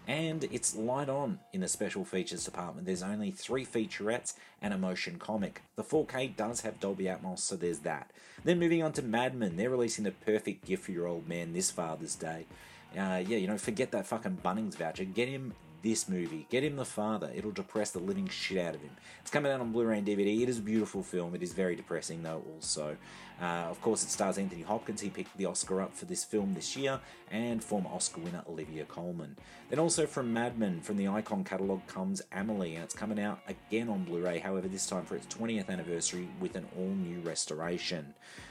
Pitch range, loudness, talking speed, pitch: 90-130 Hz, -35 LUFS, 220 wpm, 105 Hz